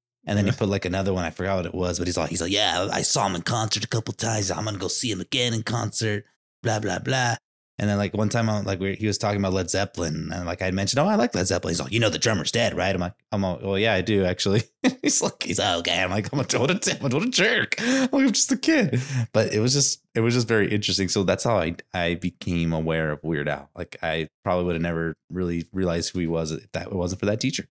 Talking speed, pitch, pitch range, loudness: 285 wpm, 100 Hz, 90-115 Hz, -24 LUFS